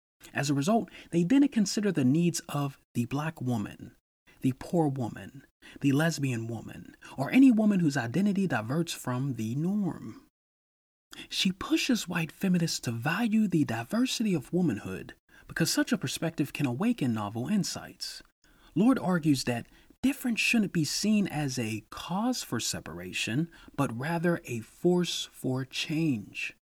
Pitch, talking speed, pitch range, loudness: 160 Hz, 140 wpm, 130-200 Hz, -29 LUFS